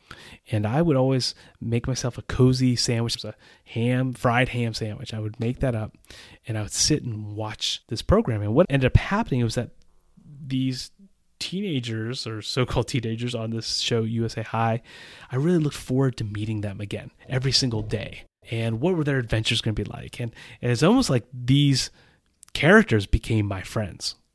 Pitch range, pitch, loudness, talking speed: 110-130 Hz, 120 Hz, -24 LUFS, 190 wpm